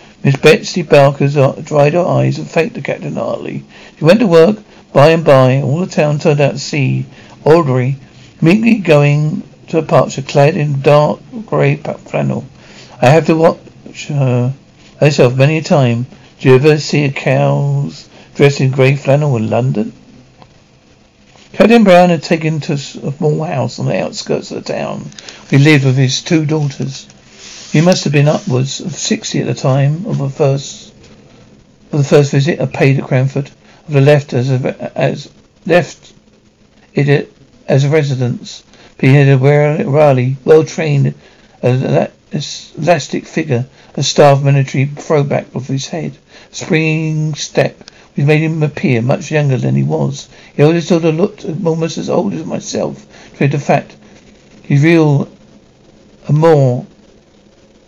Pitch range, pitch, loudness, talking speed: 135-160 Hz, 145 Hz, -12 LUFS, 160 wpm